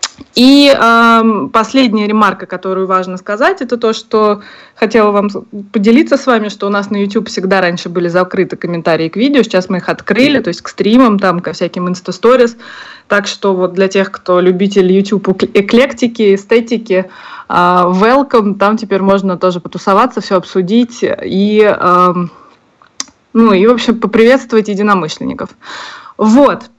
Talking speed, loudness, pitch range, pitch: 150 wpm, -11 LUFS, 185-230 Hz, 205 Hz